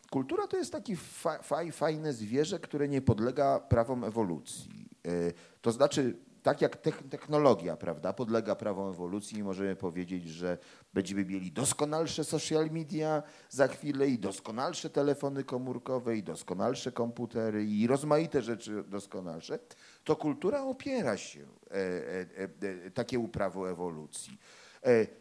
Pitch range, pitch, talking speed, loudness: 100-150 Hz, 125 Hz, 115 wpm, -33 LUFS